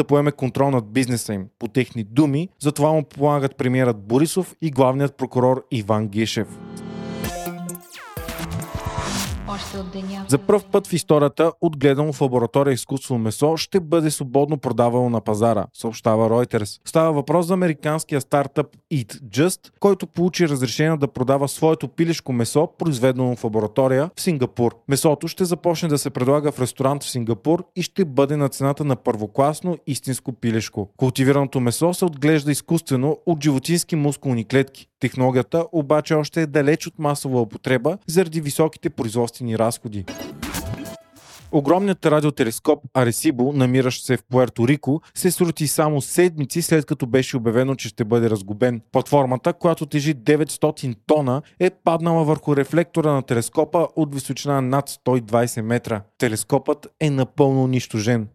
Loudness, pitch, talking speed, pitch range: -21 LUFS, 140 Hz, 140 wpm, 125-160 Hz